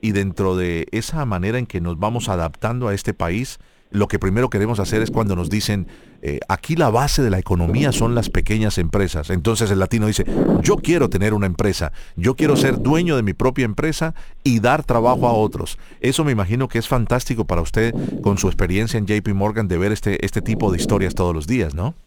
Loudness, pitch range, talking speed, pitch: -20 LUFS, 95-120 Hz, 220 wpm, 110 Hz